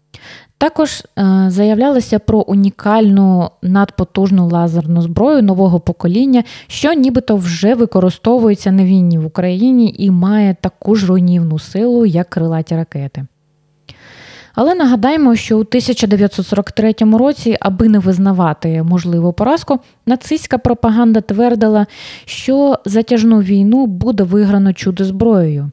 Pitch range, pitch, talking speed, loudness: 180-230 Hz, 200 Hz, 110 wpm, -12 LUFS